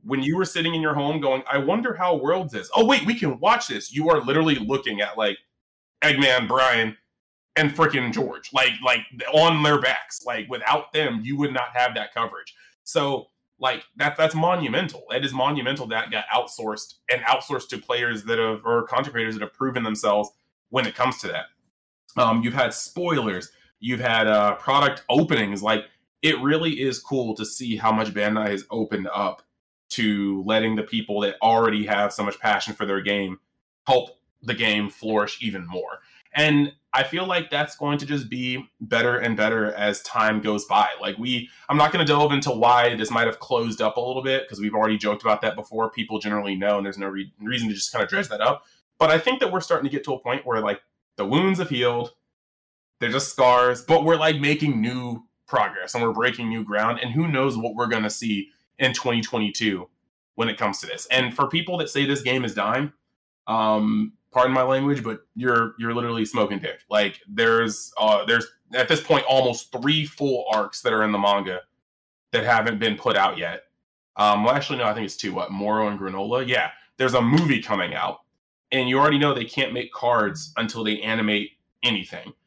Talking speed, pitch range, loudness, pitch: 205 wpm, 110-140 Hz, -23 LUFS, 120 Hz